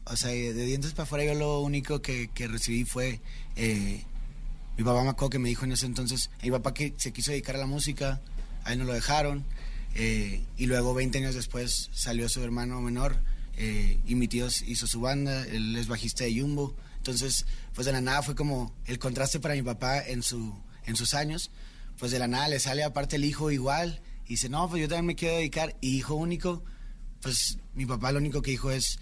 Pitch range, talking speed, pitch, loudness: 120-145 Hz, 220 wpm, 130 Hz, -30 LUFS